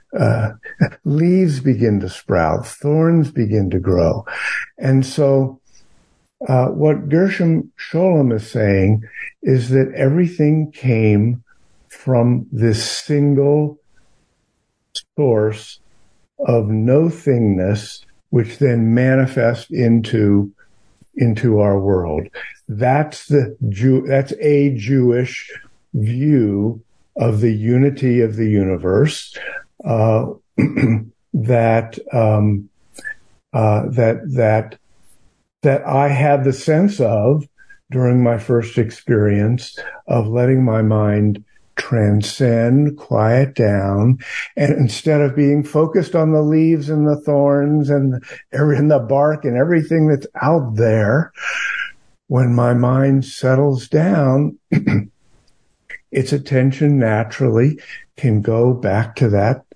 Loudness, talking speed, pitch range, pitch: -16 LUFS, 105 wpm, 110-145 Hz, 125 Hz